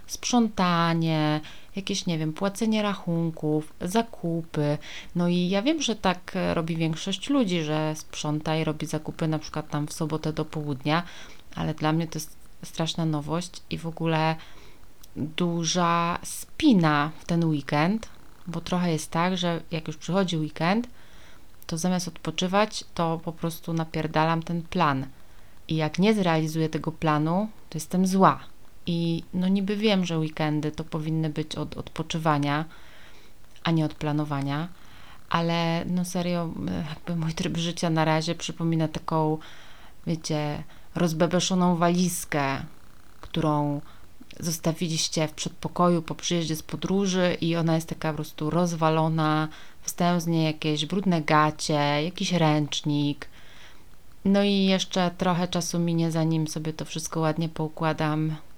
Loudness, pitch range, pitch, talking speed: -26 LUFS, 155-175 Hz, 165 Hz, 135 wpm